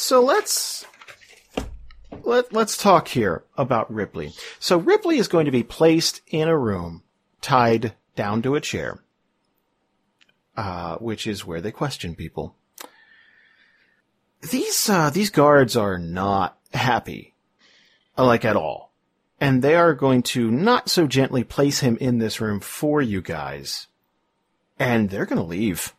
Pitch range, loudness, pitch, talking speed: 110-170 Hz, -21 LUFS, 135 Hz, 140 wpm